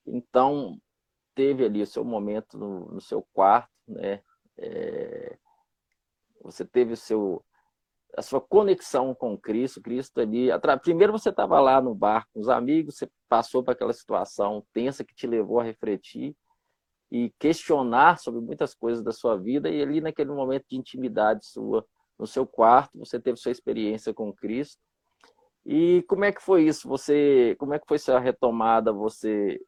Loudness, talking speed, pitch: -25 LUFS, 165 wpm, 135 Hz